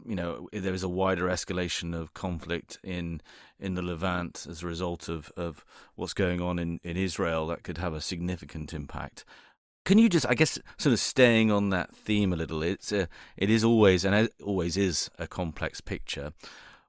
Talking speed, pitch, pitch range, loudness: 195 wpm, 90 Hz, 85-100 Hz, -29 LUFS